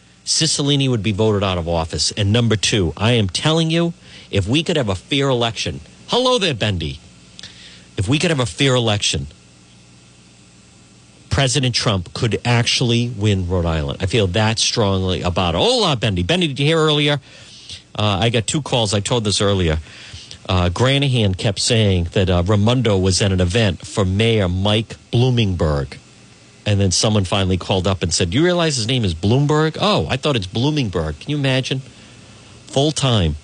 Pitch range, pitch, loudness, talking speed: 95-130 Hz, 110 Hz, -17 LUFS, 180 wpm